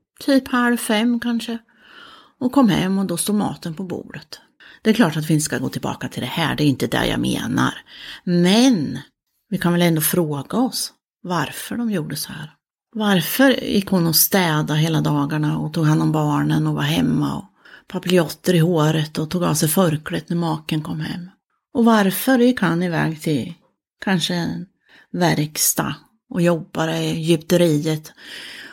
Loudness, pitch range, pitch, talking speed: -19 LUFS, 155-215 Hz, 175 Hz, 175 wpm